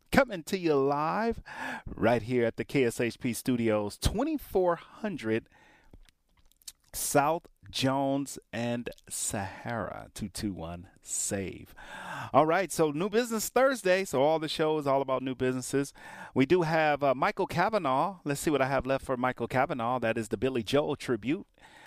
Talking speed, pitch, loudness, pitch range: 145 wpm, 135 Hz, -29 LUFS, 120-160 Hz